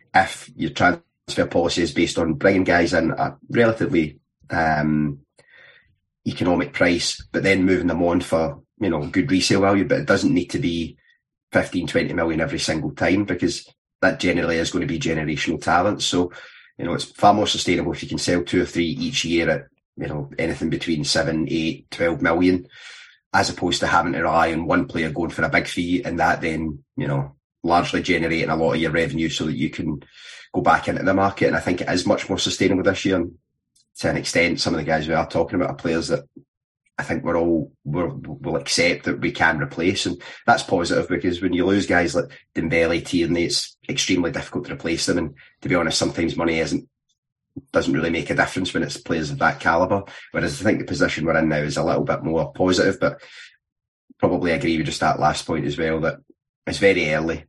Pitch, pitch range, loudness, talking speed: 85 Hz, 80-90 Hz, -21 LUFS, 215 wpm